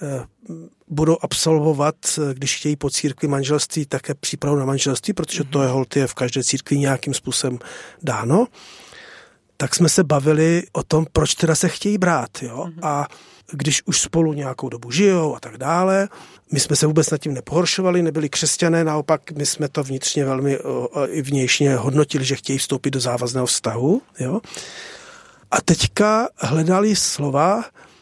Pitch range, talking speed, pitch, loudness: 135-165 Hz, 155 wpm, 150 Hz, -19 LUFS